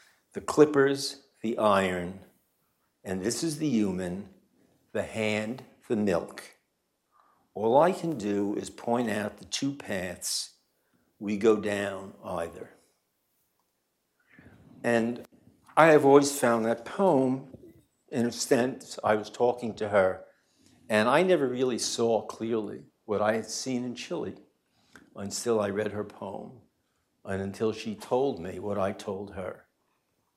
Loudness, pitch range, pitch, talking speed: -28 LUFS, 105-130 Hz, 115 Hz, 135 wpm